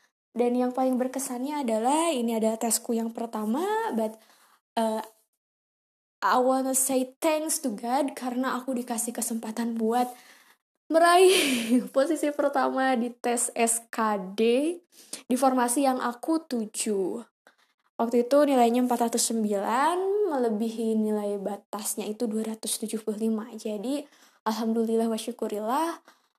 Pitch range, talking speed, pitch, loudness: 225-265 Hz, 105 wpm, 240 Hz, -26 LUFS